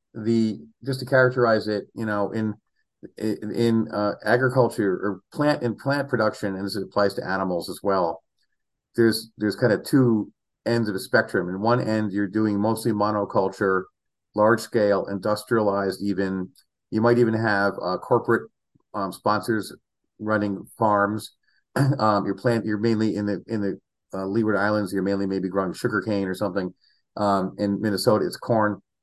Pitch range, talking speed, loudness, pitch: 100-115 Hz, 160 wpm, -24 LUFS, 105 Hz